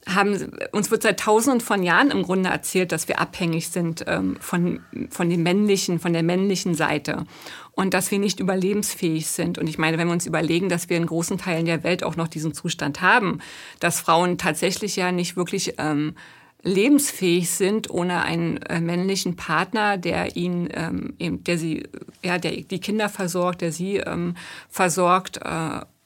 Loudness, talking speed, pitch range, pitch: -23 LUFS, 180 wpm, 165-195 Hz, 175 Hz